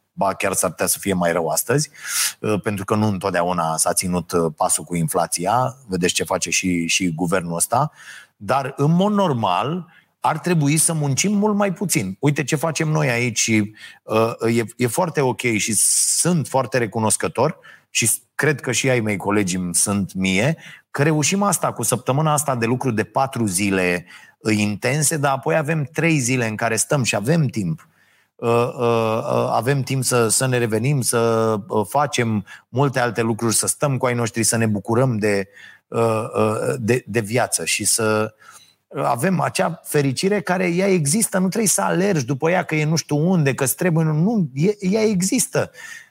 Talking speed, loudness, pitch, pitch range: 170 wpm, -19 LUFS, 125 Hz, 110-155 Hz